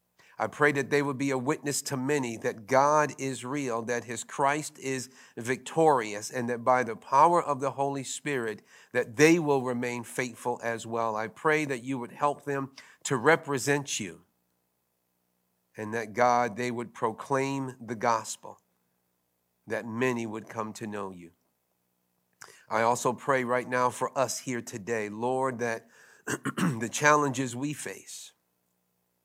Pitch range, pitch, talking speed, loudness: 105-140 Hz, 120 Hz, 155 wpm, -29 LUFS